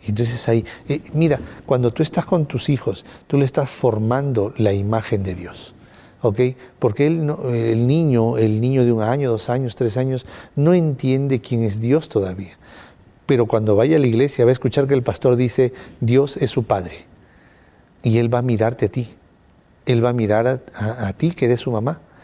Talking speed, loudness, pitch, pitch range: 205 wpm, -19 LUFS, 125 Hz, 110-135 Hz